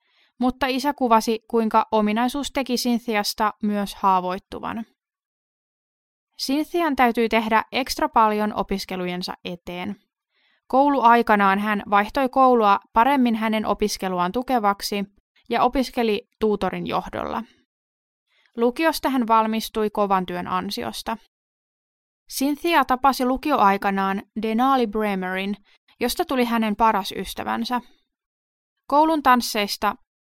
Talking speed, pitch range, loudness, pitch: 90 wpm, 205-255 Hz, -22 LUFS, 225 Hz